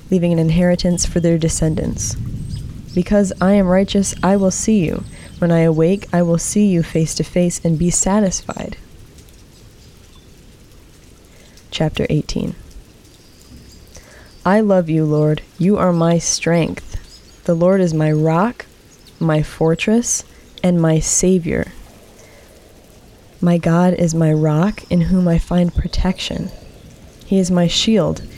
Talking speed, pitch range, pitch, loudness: 130 wpm, 160-185 Hz, 175 Hz, -16 LUFS